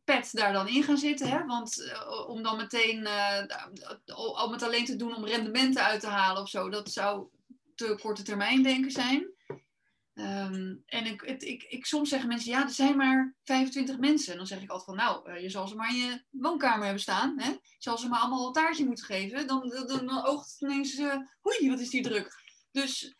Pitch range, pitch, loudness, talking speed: 215-275 Hz, 250 Hz, -30 LUFS, 220 wpm